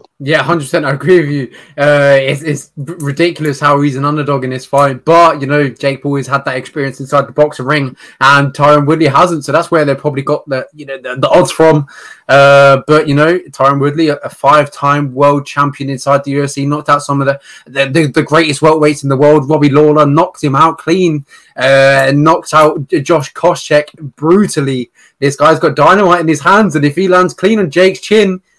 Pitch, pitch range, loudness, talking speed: 145 Hz, 140-160 Hz, -10 LUFS, 210 wpm